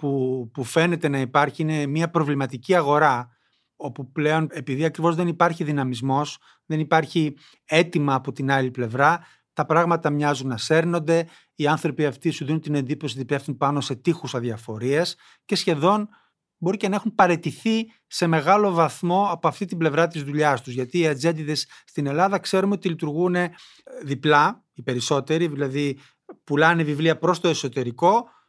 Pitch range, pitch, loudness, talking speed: 140-170 Hz, 155 Hz, -22 LUFS, 155 wpm